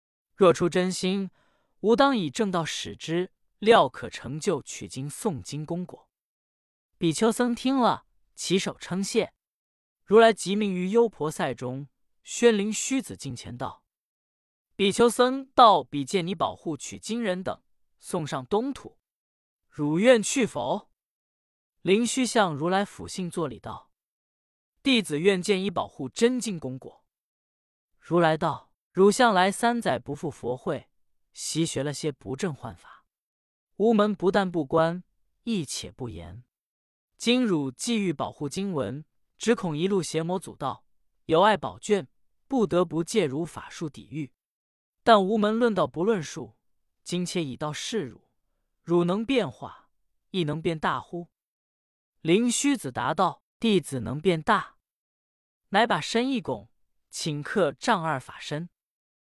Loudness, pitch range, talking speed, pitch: -26 LUFS, 130-210 Hz, 195 characters per minute, 175 Hz